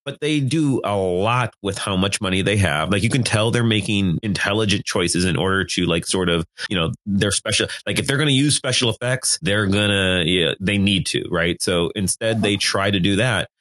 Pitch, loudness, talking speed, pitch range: 100 Hz, -19 LUFS, 230 wpm, 95-115 Hz